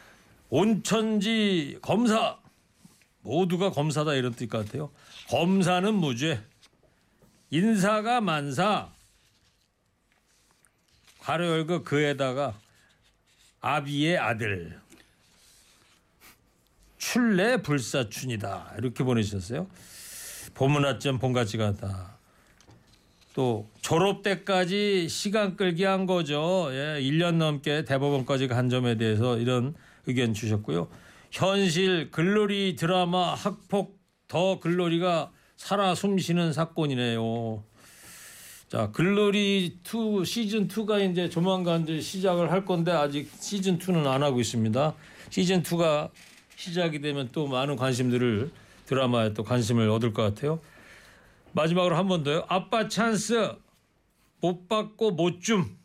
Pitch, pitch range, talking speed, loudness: 160 Hz, 125-185 Hz, 220 characters per minute, -27 LUFS